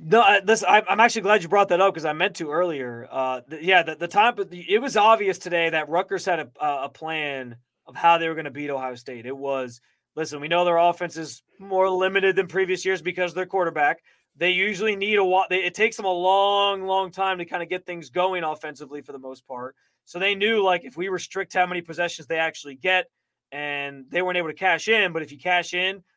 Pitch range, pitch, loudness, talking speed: 155-190 Hz, 180 Hz, -22 LUFS, 240 wpm